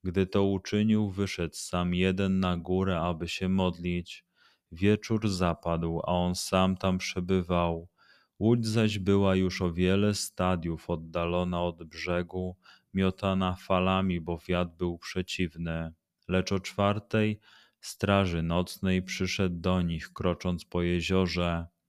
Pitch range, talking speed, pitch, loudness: 85-95 Hz, 125 wpm, 90 Hz, -29 LUFS